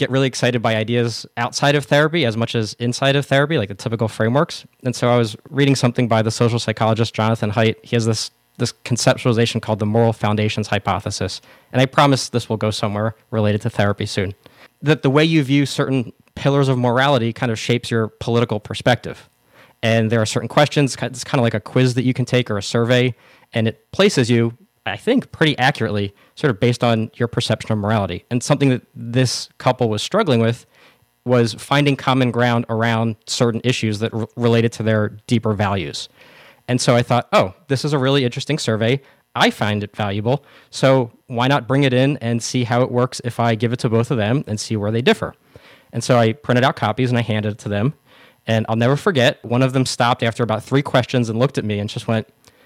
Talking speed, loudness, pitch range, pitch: 220 wpm, -19 LUFS, 110-130 Hz, 120 Hz